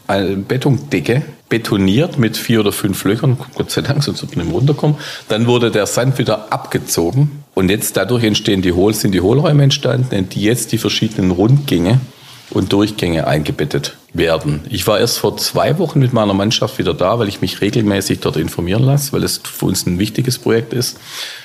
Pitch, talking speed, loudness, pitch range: 110 Hz, 185 wpm, -15 LUFS, 100-135 Hz